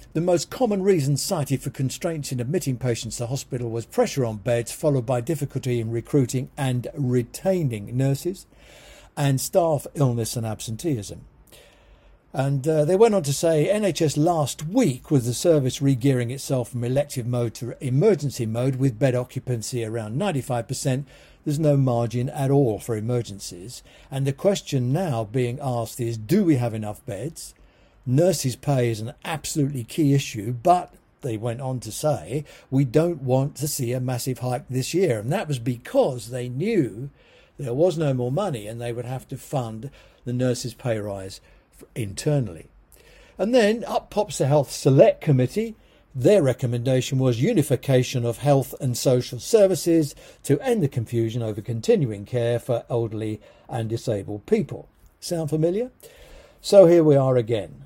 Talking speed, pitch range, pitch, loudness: 160 wpm, 120-150 Hz, 130 Hz, -23 LUFS